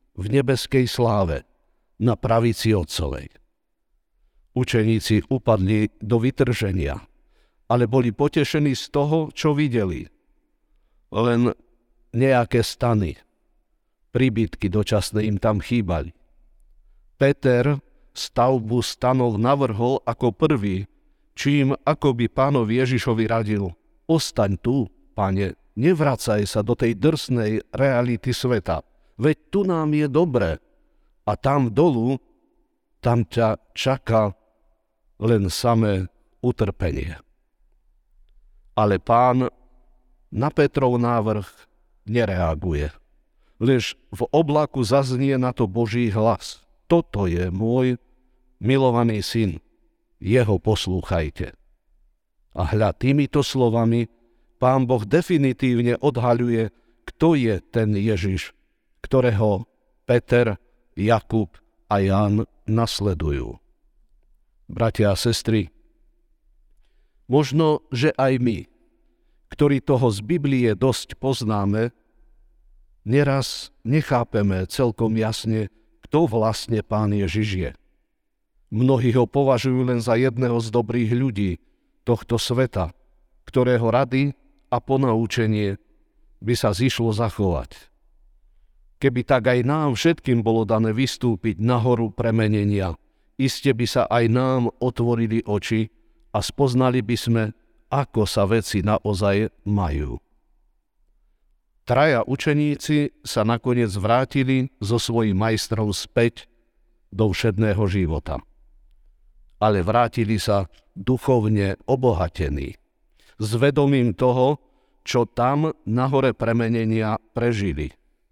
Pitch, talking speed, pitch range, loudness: 115 Hz, 95 wpm, 105-130 Hz, -22 LUFS